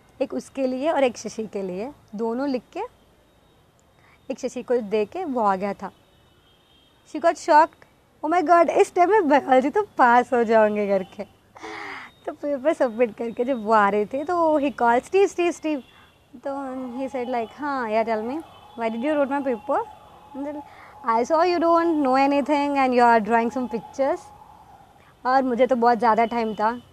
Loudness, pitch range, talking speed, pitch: -22 LUFS, 230-310 Hz, 170 wpm, 265 Hz